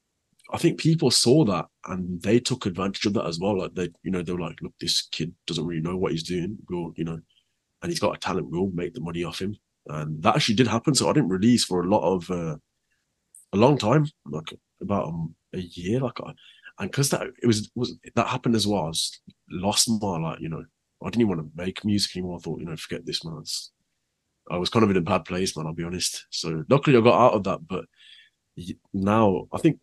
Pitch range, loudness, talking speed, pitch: 85-115 Hz, -25 LUFS, 250 wpm, 95 Hz